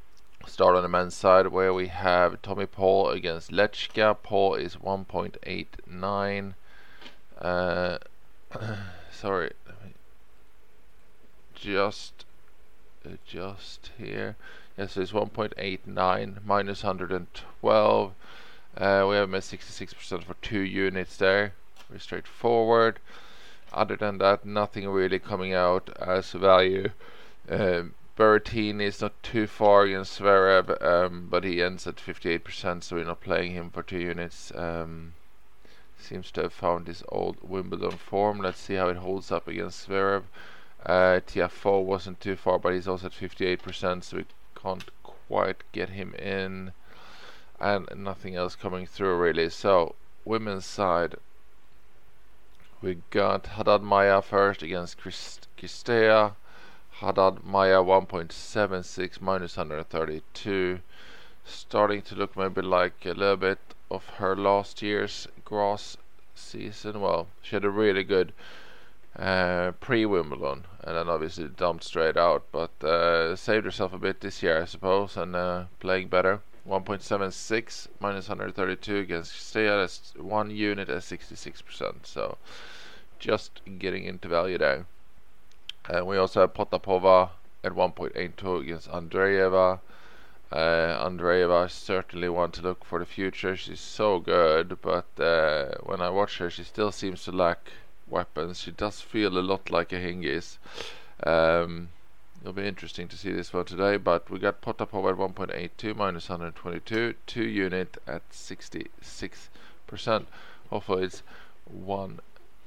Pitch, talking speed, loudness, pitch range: 95 Hz, 145 wpm, -27 LUFS, 90-100 Hz